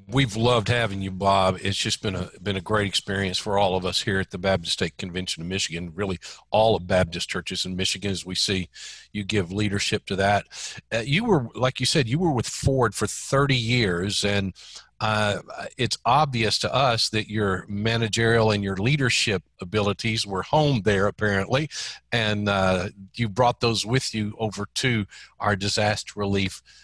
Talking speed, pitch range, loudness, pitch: 185 wpm, 95-115 Hz, -24 LUFS, 105 Hz